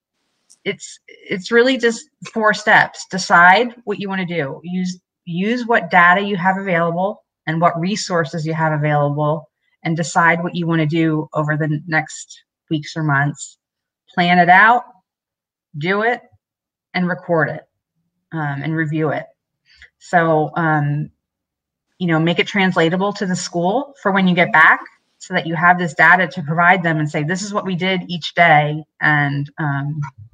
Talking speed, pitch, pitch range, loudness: 170 wpm, 170 Hz, 155-190 Hz, -16 LUFS